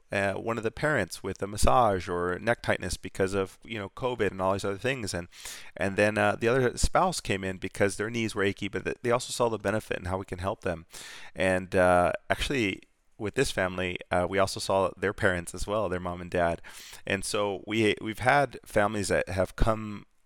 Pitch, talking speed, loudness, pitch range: 100 Hz, 220 wpm, -28 LUFS, 95-110 Hz